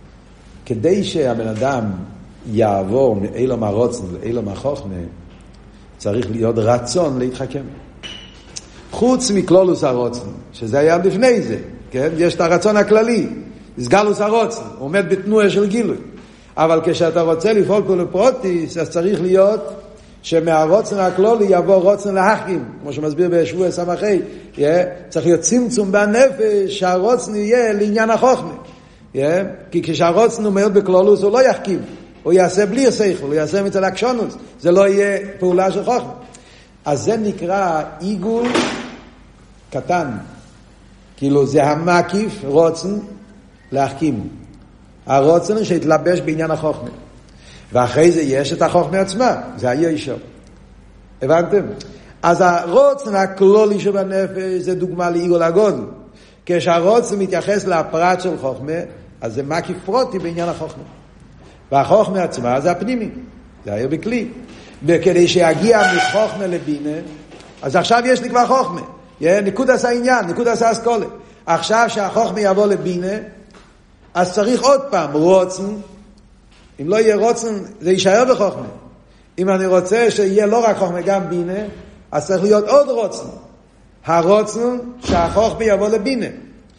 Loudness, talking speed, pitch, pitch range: -16 LUFS, 125 wpm, 185 Hz, 165-210 Hz